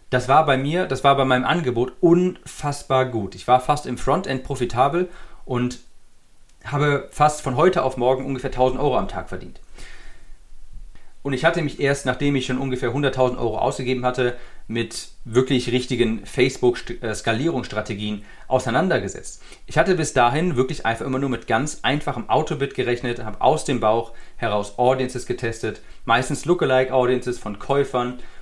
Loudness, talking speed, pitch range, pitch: -21 LUFS, 155 wpm, 120-140 Hz, 130 Hz